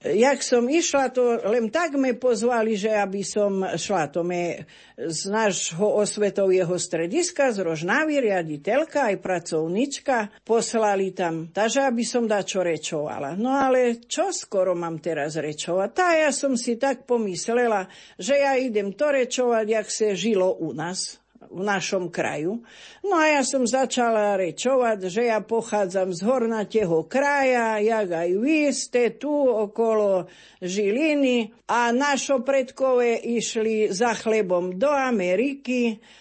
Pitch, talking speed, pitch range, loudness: 225 Hz, 140 wpm, 190-260 Hz, -23 LUFS